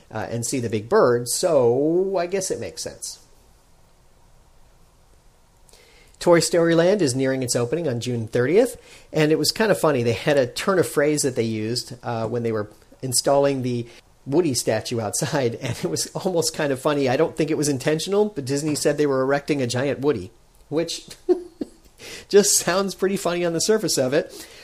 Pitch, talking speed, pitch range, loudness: 145 Hz, 190 wpm, 125-170 Hz, -21 LUFS